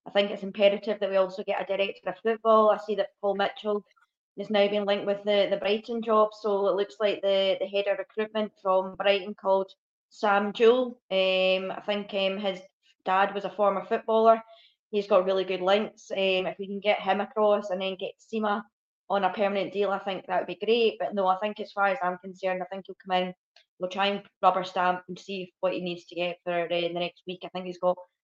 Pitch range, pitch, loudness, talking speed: 190-210 Hz, 200 Hz, -27 LUFS, 240 wpm